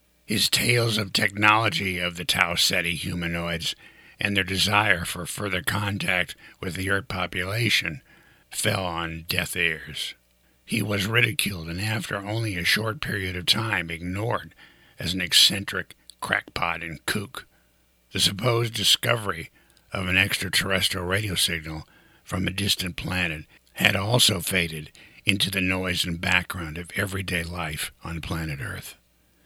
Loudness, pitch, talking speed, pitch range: -24 LUFS, 95 Hz, 135 wpm, 85-100 Hz